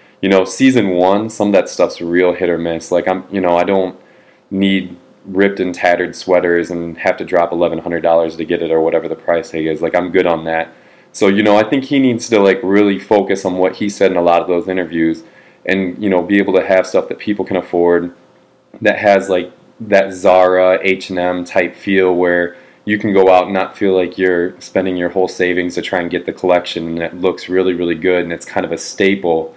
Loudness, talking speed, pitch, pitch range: -14 LUFS, 240 wpm, 90 Hz, 85-95 Hz